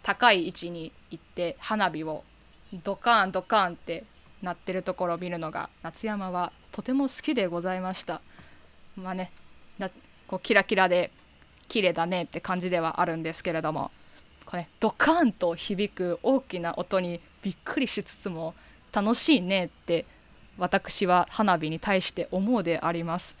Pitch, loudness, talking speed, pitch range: 185 Hz, -28 LUFS, 310 characters per minute, 170-205 Hz